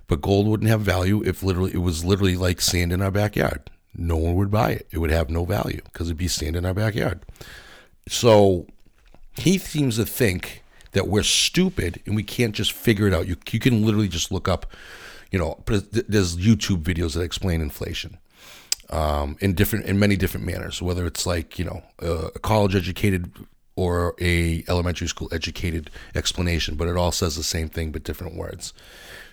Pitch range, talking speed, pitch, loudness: 85-100 Hz, 190 wpm, 90 Hz, -23 LUFS